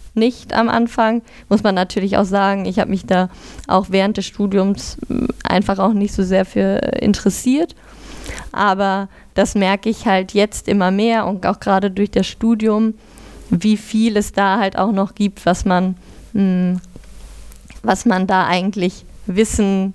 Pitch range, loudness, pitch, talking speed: 190-215 Hz, -17 LUFS, 200 Hz, 155 wpm